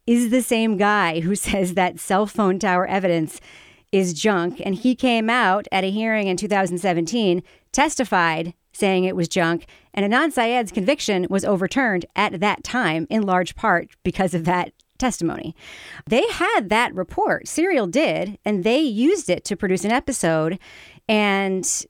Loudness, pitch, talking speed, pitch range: -21 LUFS, 200 Hz, 160 wpm, 180-235 Hz